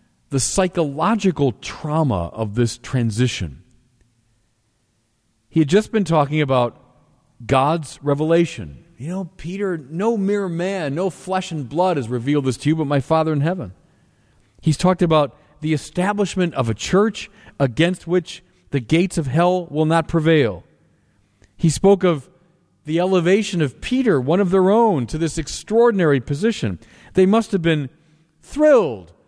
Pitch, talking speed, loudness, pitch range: 160 Hz, 145 wpm, -19 LUFS, 130-185 Hz